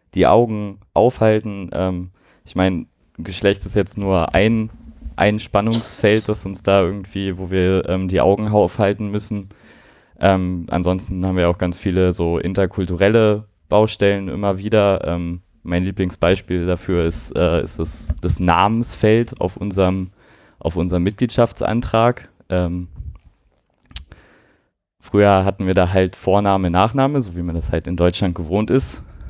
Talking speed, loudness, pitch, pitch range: 140 wpm, -18 LUFS, 95 Hz, 90-105 Hz